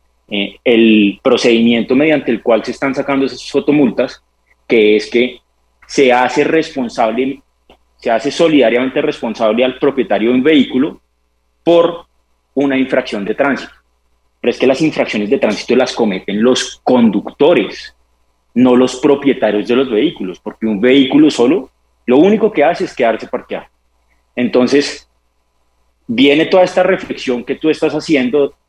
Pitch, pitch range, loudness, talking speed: 125 Hz, 100-140 Hz, -13 LUFS, 140 wpm